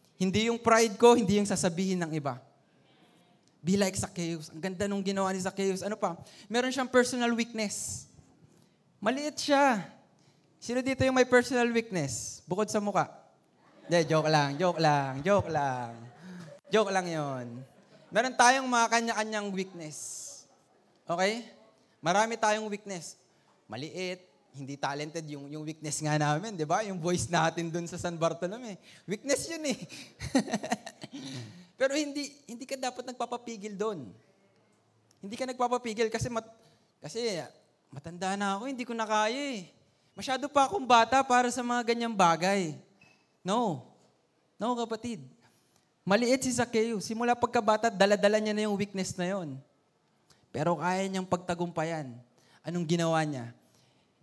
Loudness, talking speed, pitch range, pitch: -29 LUFS, 140 wpm, 165-230 Hz, 195 Hz